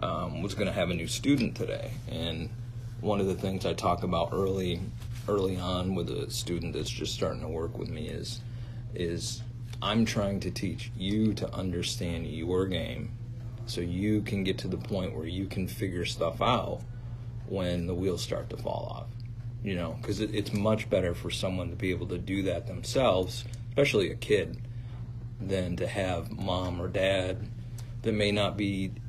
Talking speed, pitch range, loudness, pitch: 185 wpm, 95-120 Hz, -31 LUFS, 105 Hz